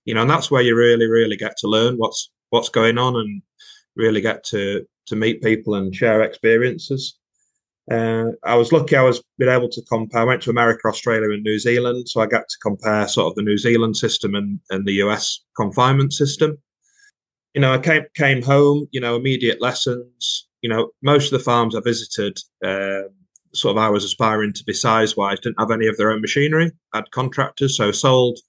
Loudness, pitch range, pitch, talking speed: -18 LUFS, 110-135 Hz, 120 Hz, 205 wpm